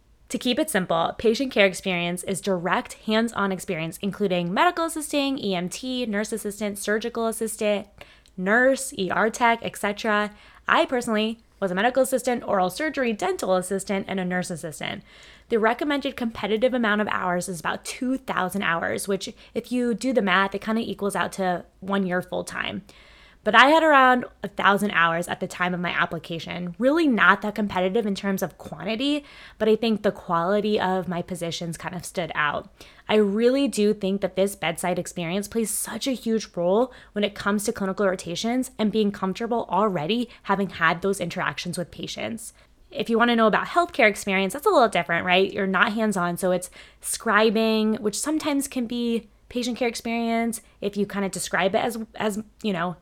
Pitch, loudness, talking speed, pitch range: 205 Hz, -24 LUFS, 180 wpm, 185-230 Hz